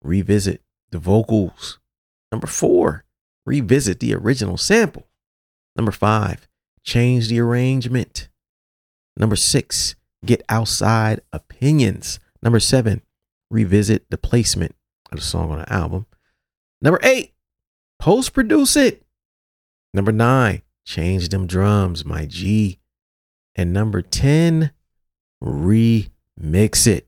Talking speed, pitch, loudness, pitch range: 100 wpm, 100 Hz, -18 LUFS, 80-115 Hz